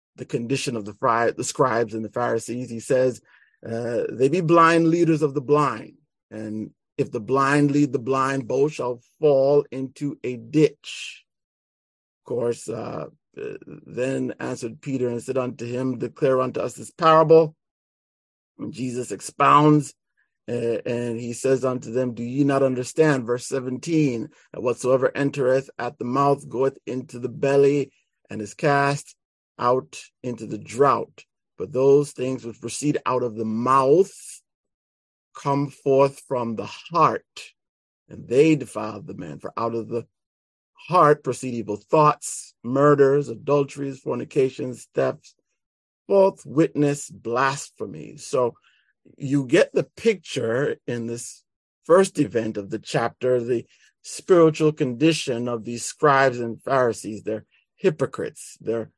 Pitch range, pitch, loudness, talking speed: 115-145 Hz, 130 Hz, -22 LUFS, 140 wpm